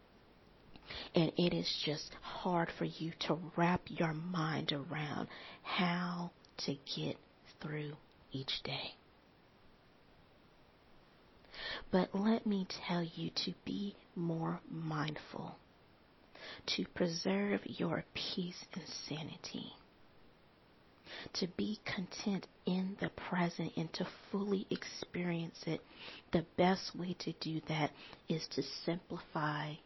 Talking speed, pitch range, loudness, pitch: 105 wpm, 155-185 Hz, -39 LUFS, 170 Hz